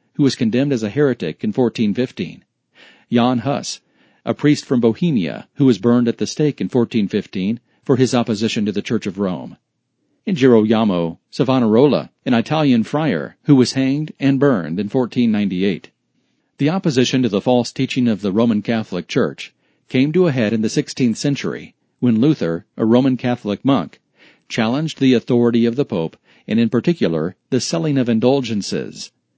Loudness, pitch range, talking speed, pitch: -18 LUFS, 110-140 Hz, 165 wpm, 125 Hz